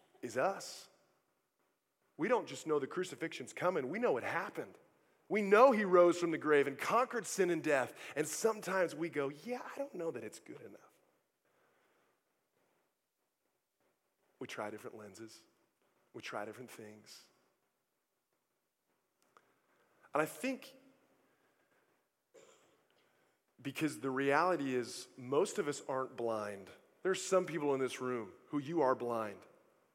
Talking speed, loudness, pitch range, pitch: 135 wpm, -35 LUFS, 130-220 Hz, 160 Hz